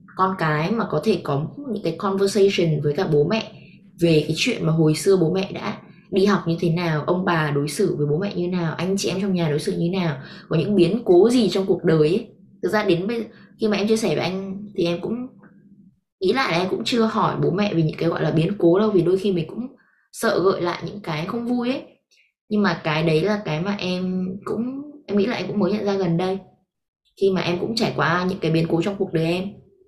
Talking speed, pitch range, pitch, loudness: 260 wpm, 170-205 Hz, 190 Hz, -21 LUFS